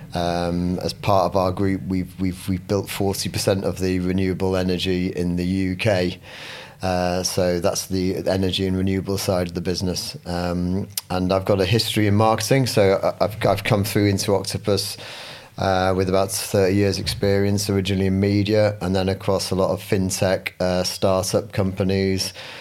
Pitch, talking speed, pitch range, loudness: 95 Hz, 165 wpm, 90-100 Hz, -21 LUFS